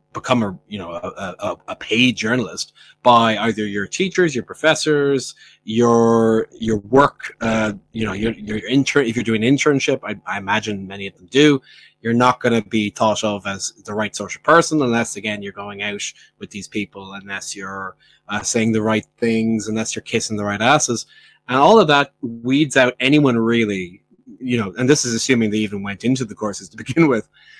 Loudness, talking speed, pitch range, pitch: -18 LUFS, 200 wpm, 105-135 Hz, 115 Hz